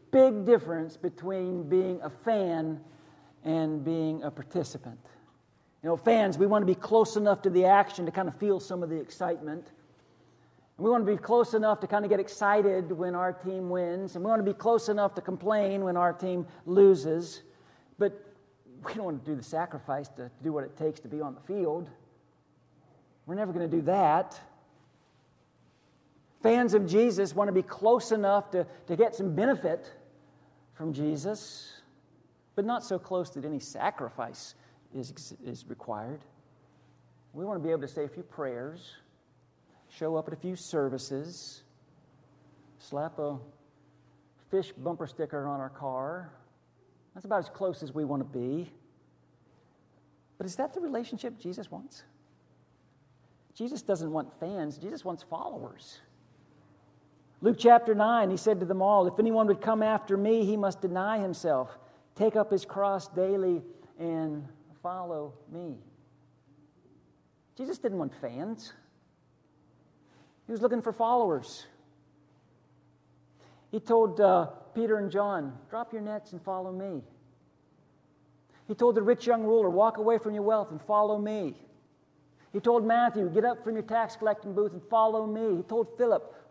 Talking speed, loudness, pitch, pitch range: 160 wpm, -29 LUFS, 180 Hz, 150-210 Hz